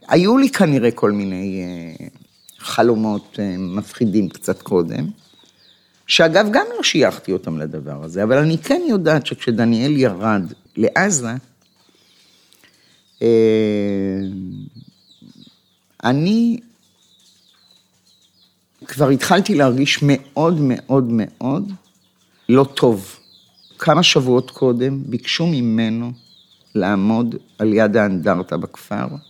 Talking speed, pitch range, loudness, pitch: 85 wpm, 105-145 Hz, -17 LUFS, 120 Hz